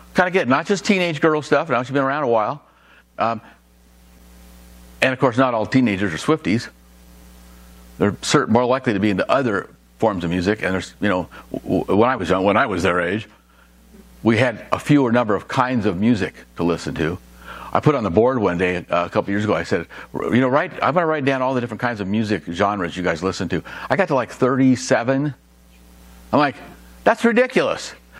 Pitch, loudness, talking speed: 100 Hz, -19 LUFS, 215 wpm